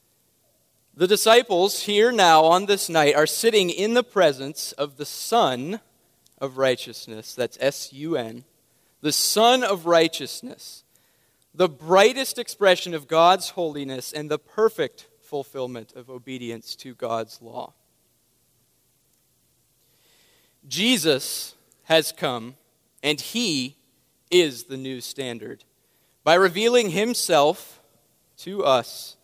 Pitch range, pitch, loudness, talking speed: 130-195 Hz, 155 Hz, -21 LUFS, 110 wpm